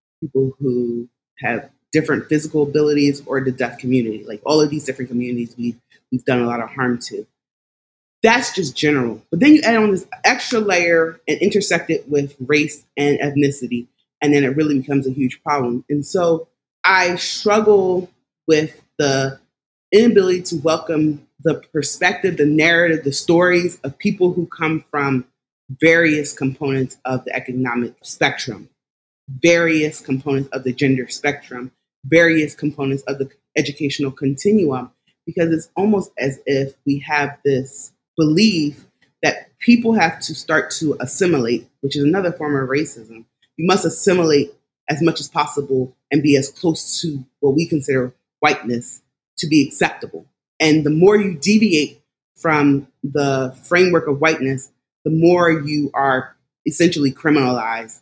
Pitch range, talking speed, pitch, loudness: 130-165 Hz, 150 wpm, 145 Hz, -18 LUFS